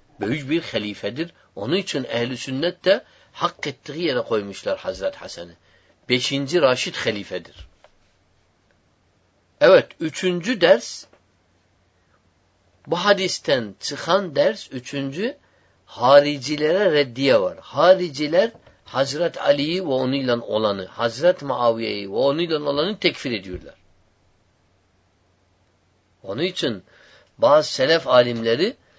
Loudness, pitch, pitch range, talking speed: -21 LUFS, 120 Hz, 95-160 Hz, 95 wpm